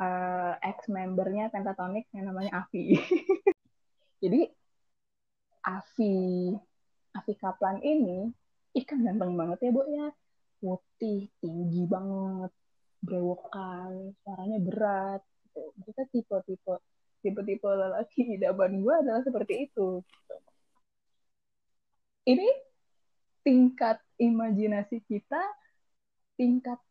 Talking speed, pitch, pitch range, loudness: 85 wpm, 205 Hz, 190-245 Hz, -30 LUFS